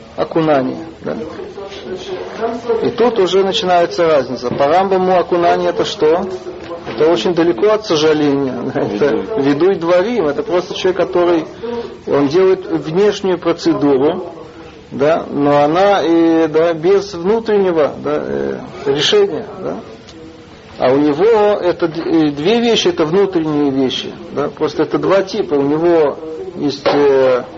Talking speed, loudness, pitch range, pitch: 125 wpm, -14 LUFS, 150-195 Hz, 170 Hz